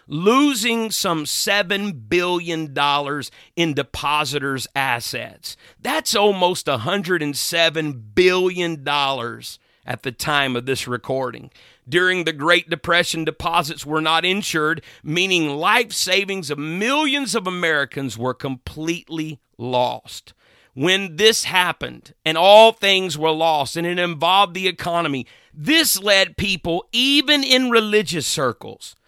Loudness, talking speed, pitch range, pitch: -18 LUFS, 115 wpm, 145-195 Hz, 170 Hz